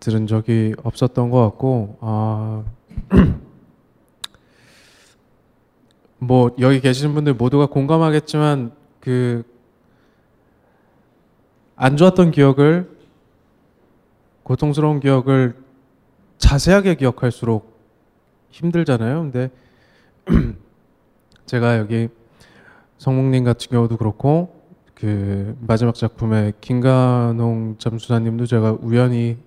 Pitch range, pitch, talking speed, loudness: 115-140 Hz, 125 Hz, 190 characters per minute, -18 LUFS